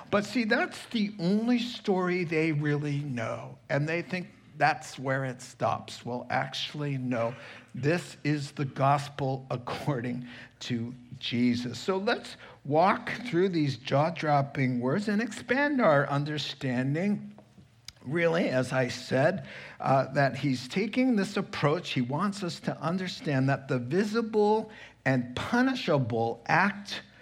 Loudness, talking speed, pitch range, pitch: -29 LUFS, 130 wpm, 130-190 Hz, 145 Hz